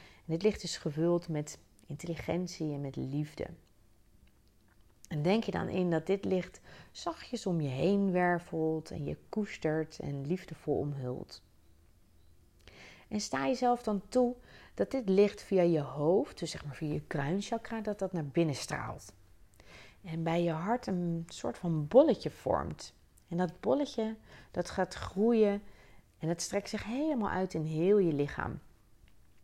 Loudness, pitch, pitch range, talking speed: -33 LUFS, 170 Hz, 145-195 Hz, 155 wpm